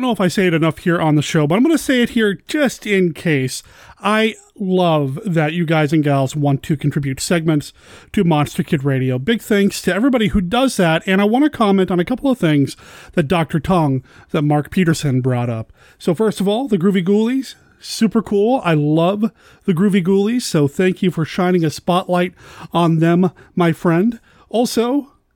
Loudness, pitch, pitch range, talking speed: -17 LUFS, 180 Hz, 155-210 Hz, 205 wpm